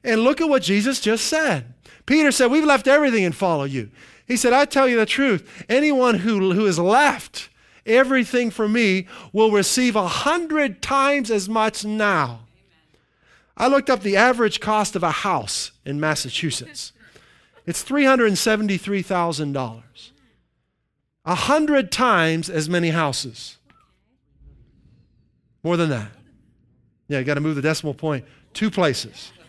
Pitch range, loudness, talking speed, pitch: 150-250 Hz, -20 LUFS, 140 wpm, 200 Hz